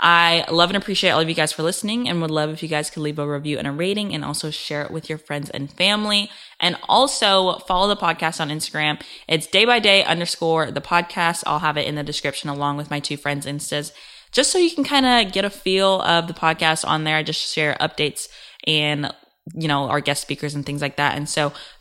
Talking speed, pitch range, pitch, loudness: 240 wpm, 145-185 Hz, 160 Hz, -20 LUFS